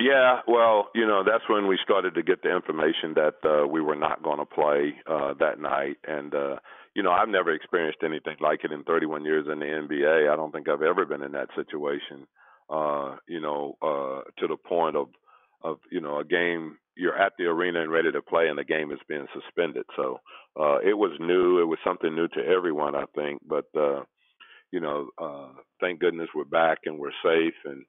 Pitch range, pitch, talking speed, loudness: 75-80 Hz, 75 Hz, 215 wpm, -26 LUFS